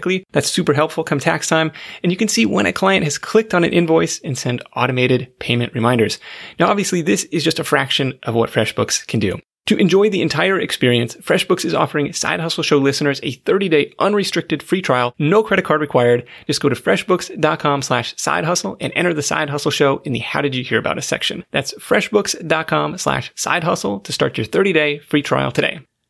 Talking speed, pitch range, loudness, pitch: 200 wpm, 130-175 Hz, -17 LUFS, 150 Hz